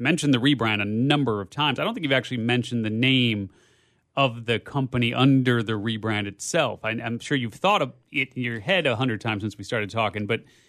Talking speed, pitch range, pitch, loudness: 225 wpm, 110-130 Hz, 120 Hz, -24 LUFS